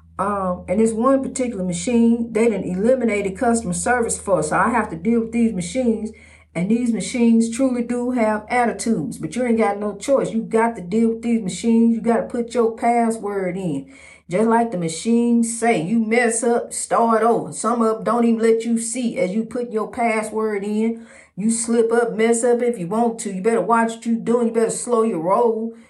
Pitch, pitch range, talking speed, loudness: 230 Hz, 220-235 Hz, 215 wpm, -20 LUFS